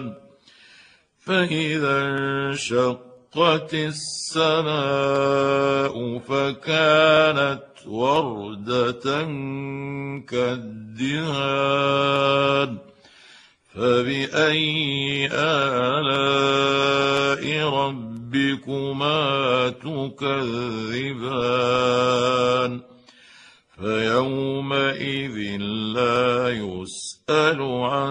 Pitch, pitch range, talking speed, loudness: 140 Hz, 125-140 Hz, 30 wpm, -22 LUFS